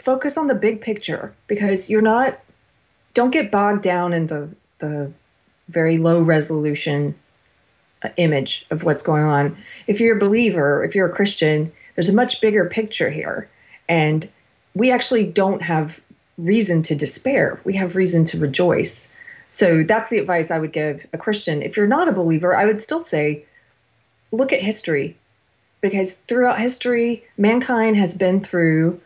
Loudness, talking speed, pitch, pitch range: -19 LUFS, 160 wpm, 185 Hz, 160-220 Hz